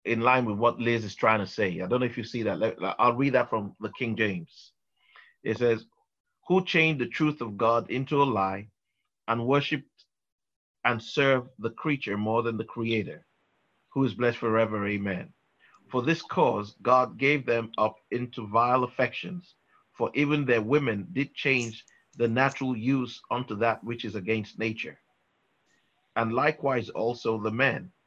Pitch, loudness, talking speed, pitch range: 120 Hz, -27 LUFS, 170 wpm, 110-135 Hz